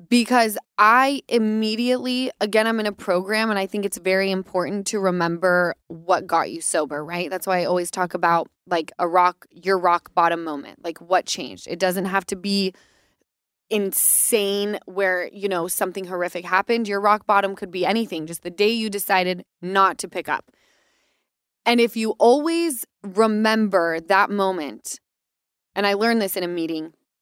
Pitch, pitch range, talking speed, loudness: 195 Hz, 180-215 Hz, 170 wpm, -21 LUFS